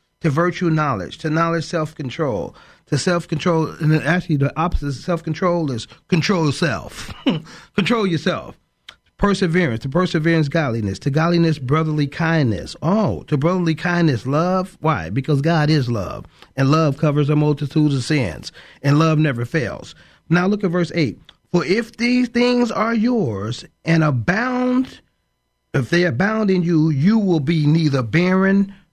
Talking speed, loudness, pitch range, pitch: 155 wpm, -19 LUFS, 150-180 Hz, 160 Hz